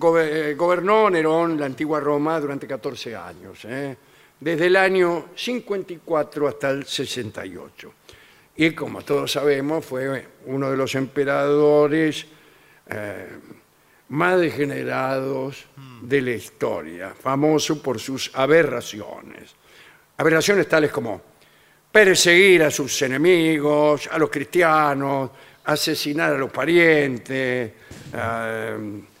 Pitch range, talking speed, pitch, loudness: 135-160 Hz, 105 wpm, 145 Hz, -20 LUFS